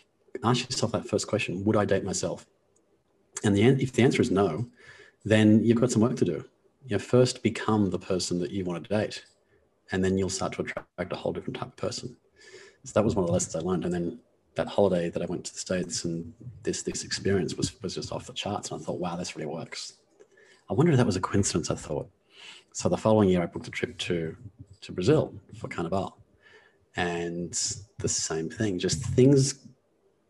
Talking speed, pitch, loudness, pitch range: 220 wpm, 105 Hz, -27 LUFS, 90-125 Hz